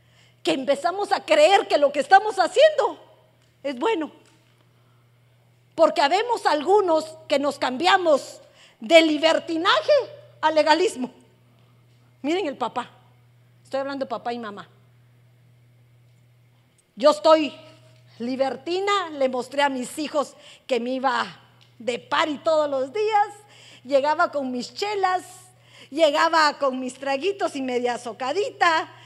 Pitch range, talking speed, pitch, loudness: 220-325 Hz, 120 wpm, 280 Hz, -22 LUFS